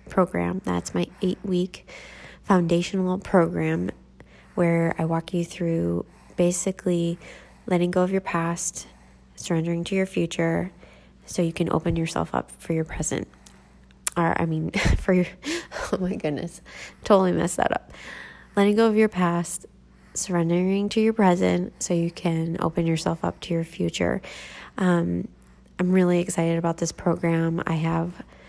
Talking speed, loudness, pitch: 145 wpm, -24 LUFS, 170 Hz